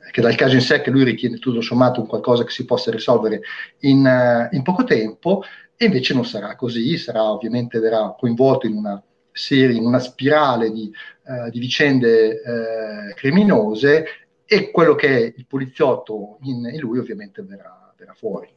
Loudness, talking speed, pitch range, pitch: -18 LUFS, 180 wpm, 115-135 Hz, 120 Hz